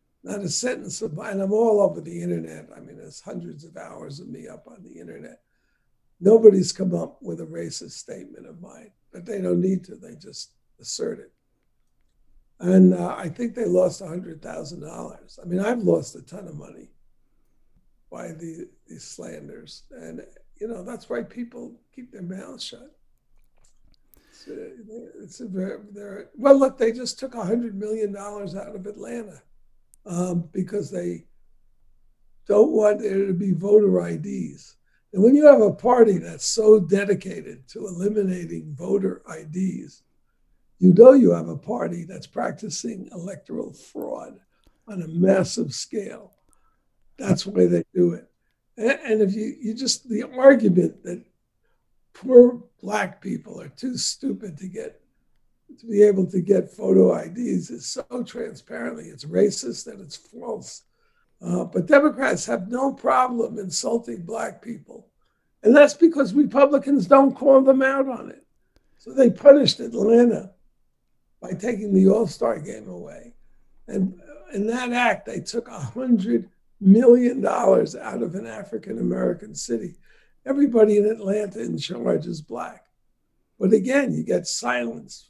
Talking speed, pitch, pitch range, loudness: 150 wpm, 215 Hz, 190-245 Hz, -20 LUFS